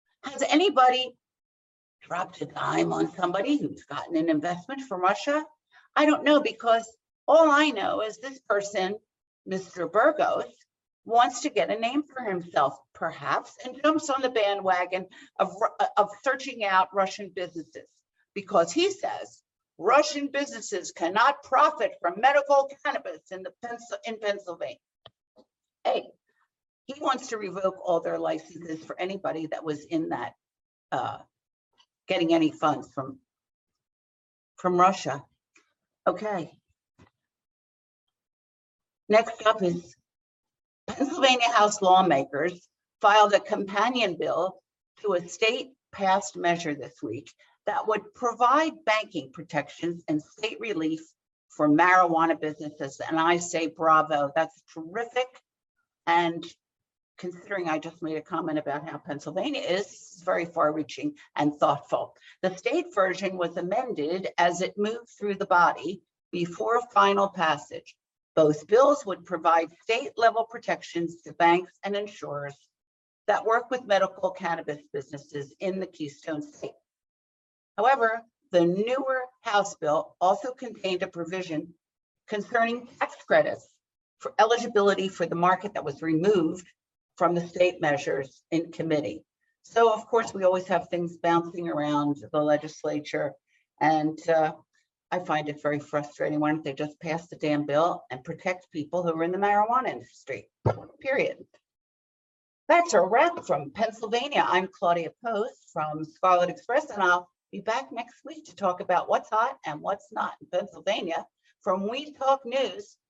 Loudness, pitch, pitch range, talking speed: -26 LUFS, 185 Hz, 160-235 Hz, 135 wpm